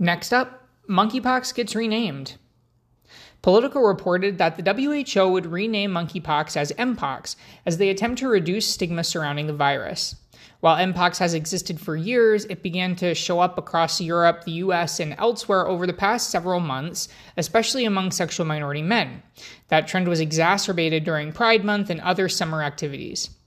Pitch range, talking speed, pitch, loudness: 165-205 Hz, 160 wpm, 180 Hz, -22 LUFS